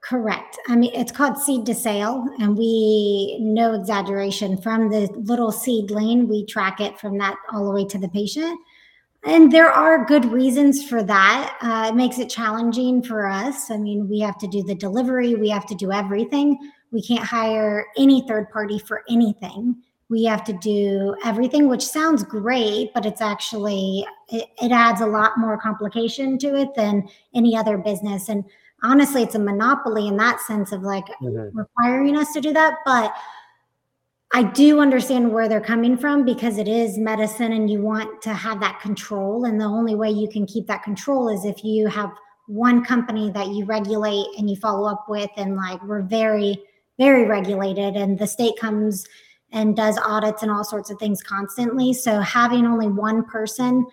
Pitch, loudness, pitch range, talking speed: 220 Hz, -20 LUFS, 205-240 Hz, 185 wpm